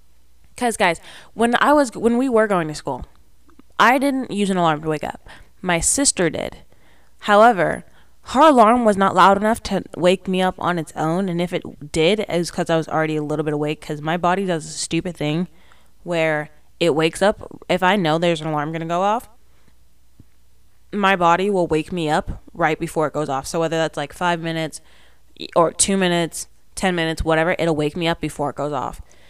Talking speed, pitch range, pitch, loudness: 210 wpm, 150-185 Hz, 165 Hz, -19 LUFS